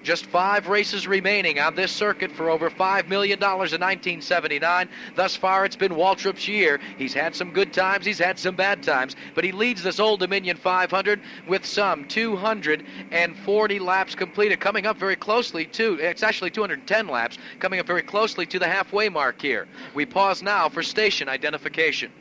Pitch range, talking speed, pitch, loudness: 175-205 Hz, 175 wpm, 190 Hz, -23 LUFS